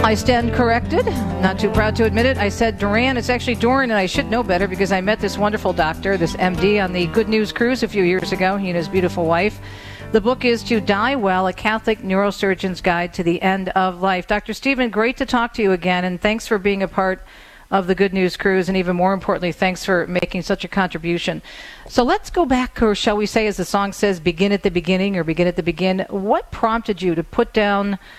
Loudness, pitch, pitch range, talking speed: -19 LUFS, 195 Hz, 185-220 Hz, 240 wpm